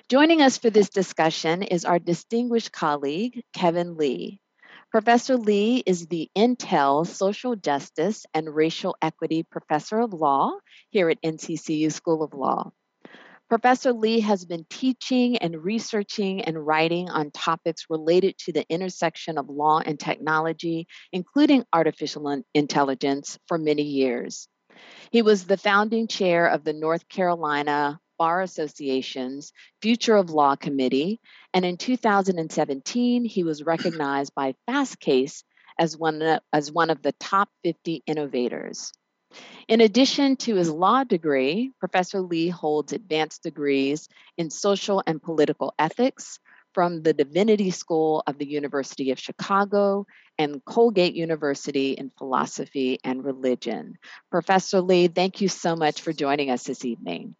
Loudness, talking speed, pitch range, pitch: -24 LUFS, 135 wpm, 150-200 Hz, 165 Hz